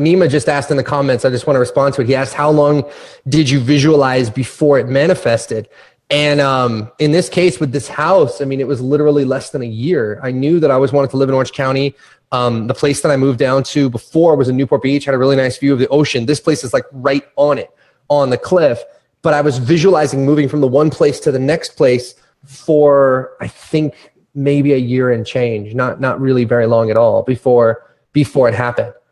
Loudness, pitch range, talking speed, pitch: -14 LUFS, 130-145 Hz, 235 wpm, 140 Hz